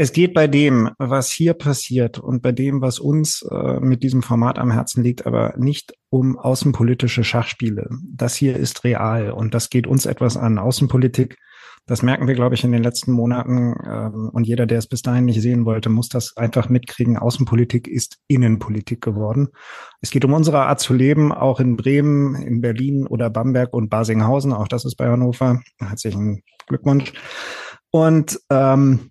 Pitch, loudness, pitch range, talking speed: 125 Hz, -18 LUFS, 120-135 Hz, 180 wpm